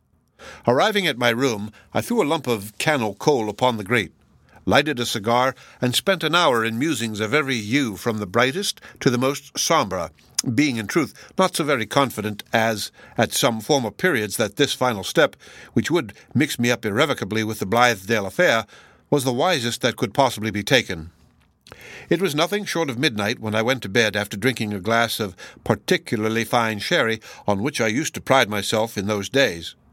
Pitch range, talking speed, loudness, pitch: 110-140 Hz, 195 wpm, -21 LUFS, 120 Hz